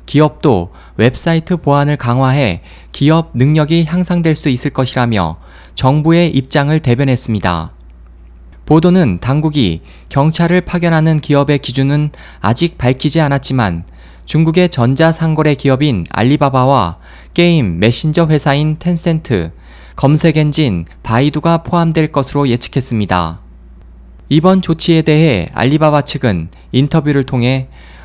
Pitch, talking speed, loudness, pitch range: 140 Hz, 285 characters per minute, -12 LUFS, 110-160 Hz